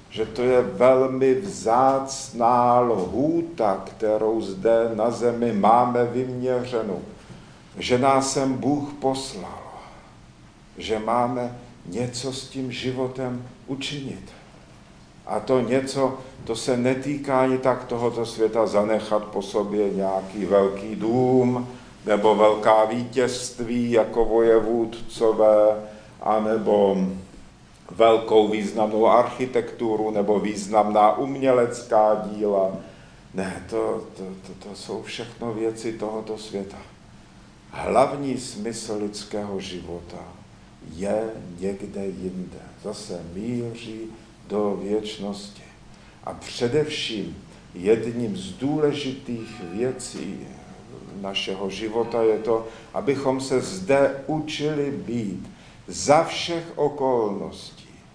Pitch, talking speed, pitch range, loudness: 115 Hz, 95 wpm, 105-130 Hz, -23 LUFS